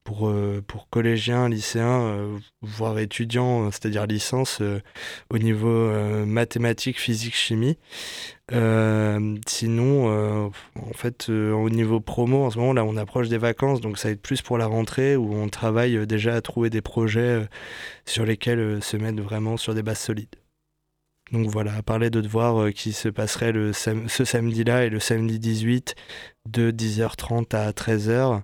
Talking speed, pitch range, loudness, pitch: 155 wpm, 105-120 Hz, -24 LUFS, 115 Hz